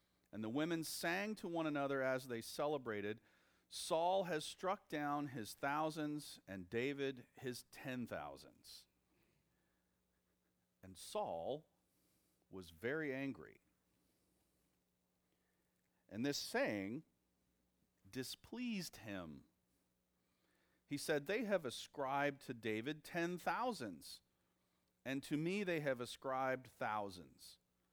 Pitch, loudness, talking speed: 120 Hz, -43 LUFS, 100 wpm